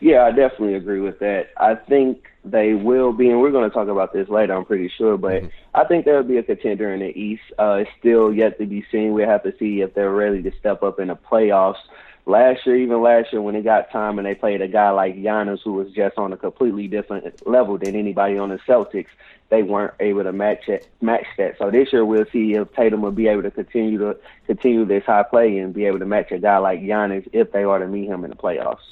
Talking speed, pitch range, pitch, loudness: 255 wpm, 100-110 Hz, 105 Hz, -19 LUFS